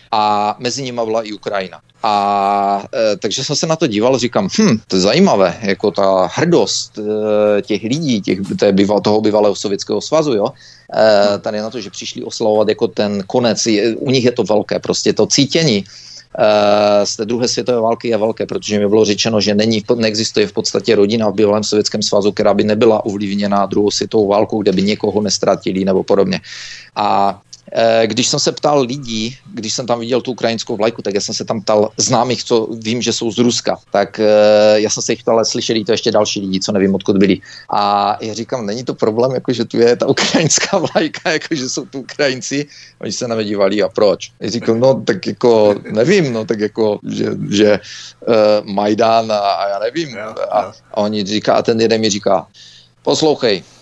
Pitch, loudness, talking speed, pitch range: 110 Hz, -15 LUFS, 200 wpm, 105-120 Hz